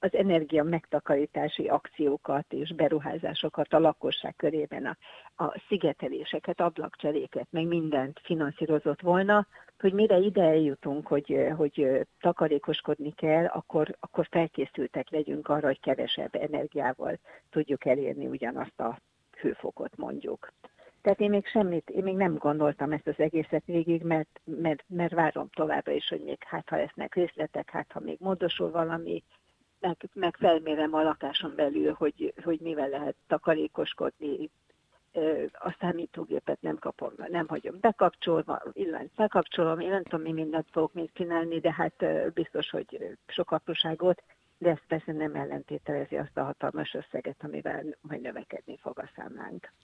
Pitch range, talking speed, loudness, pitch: 155-175 Hz, 140 wpm, -30 LUFS, 160 Hz